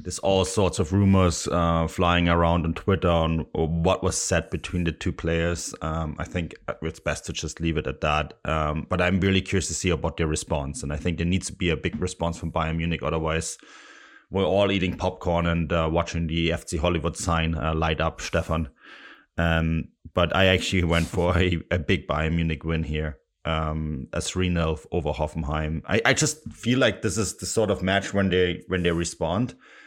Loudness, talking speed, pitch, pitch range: -25 LUFS, 210 wpm, 85 Hz, 80-90 Hz